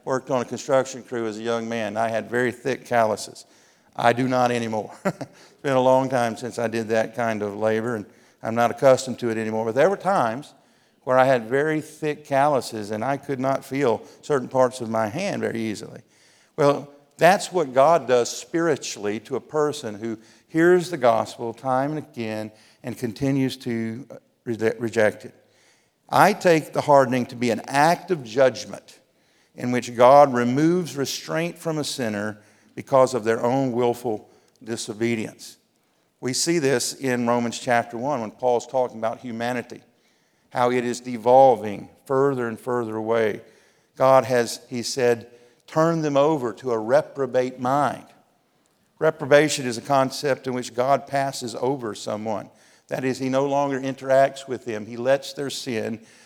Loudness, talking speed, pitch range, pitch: -23 LUFS, 170 wpm, 115-135 Hz, 125 Hz